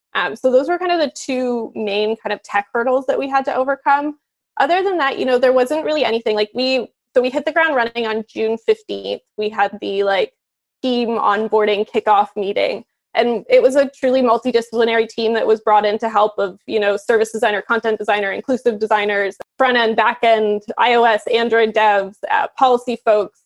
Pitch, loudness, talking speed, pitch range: 230 Hz, -17 LUFS, 200 wpm, 210-255 Hz